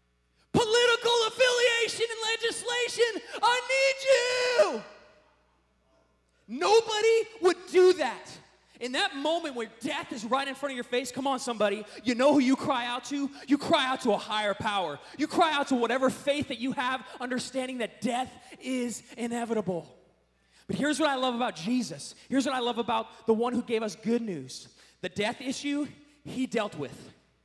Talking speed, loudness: 175 wpm, -28 LUFS